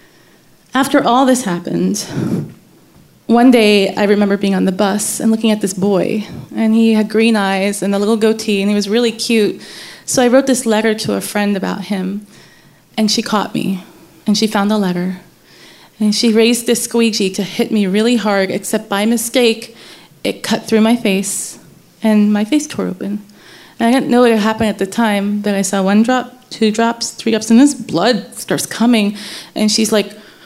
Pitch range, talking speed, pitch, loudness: 200-230 Hz, 195 wpm, 215 Hz, -14 LUFS